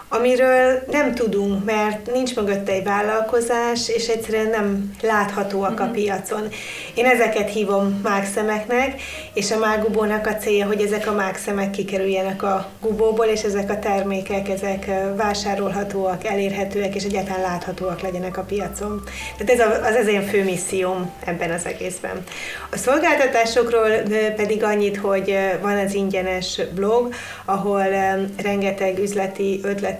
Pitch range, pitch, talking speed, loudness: 195-220 Hz, 205 Hz, 135 wpm, -21 LUFS